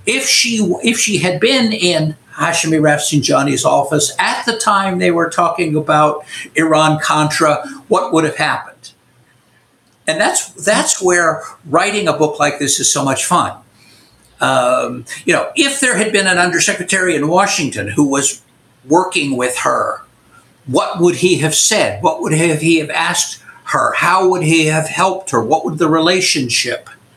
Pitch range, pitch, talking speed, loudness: 150-185 Hz, 165 Hz, 160 wpm, -14 LUFS